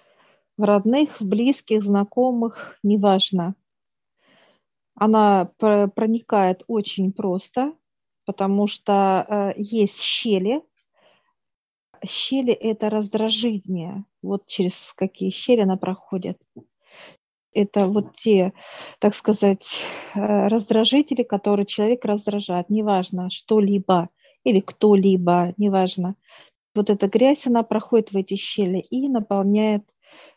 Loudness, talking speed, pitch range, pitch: -21 LUFS, 95 wpm, 195-230 Hz, 205 Hz